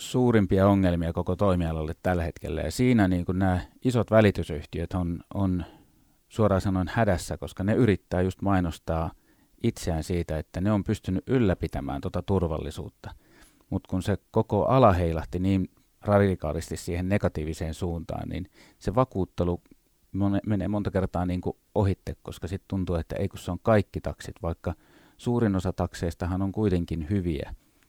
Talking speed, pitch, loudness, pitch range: 150 wpm, 95 Hz, -27 LUFS, 85-100 Hz